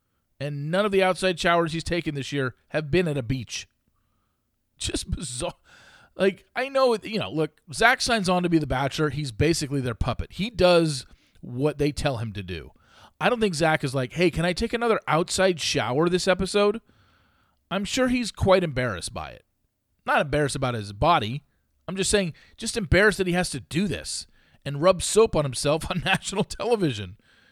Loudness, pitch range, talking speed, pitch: -24 LUFS, 135-190 Hz, 190 wpm, 160 Hz